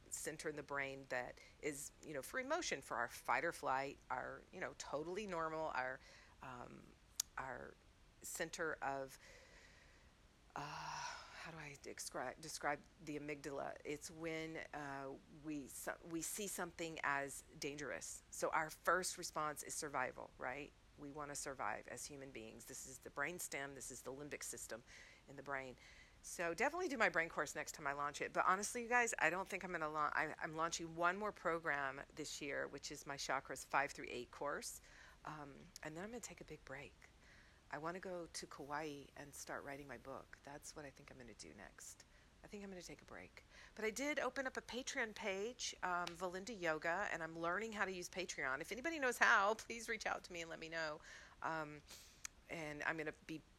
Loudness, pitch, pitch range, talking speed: -44 LUFS, 160 Hz, 140-185 Hz, 200 wpm